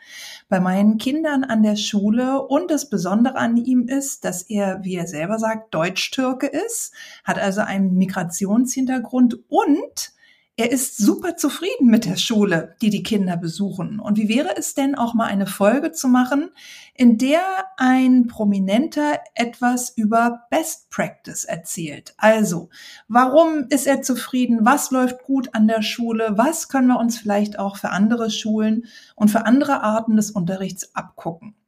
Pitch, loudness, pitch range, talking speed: 230 Hz, -19 LUFS, 205-270 Hz, 155 wpm